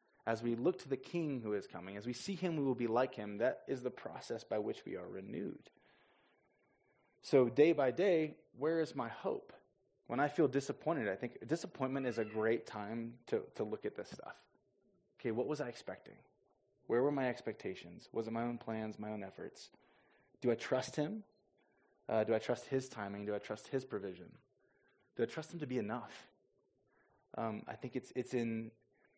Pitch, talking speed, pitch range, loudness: 125 Hz, 200 wpm, 115-145 Hz, -39 LUFS